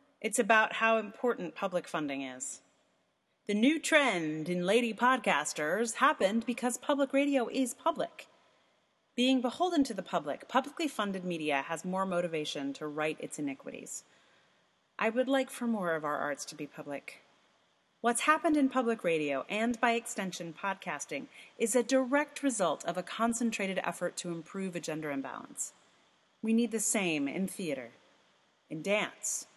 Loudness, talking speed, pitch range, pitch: -32 LUFS, 150 wpm, 170-250 Hz, 215 Hz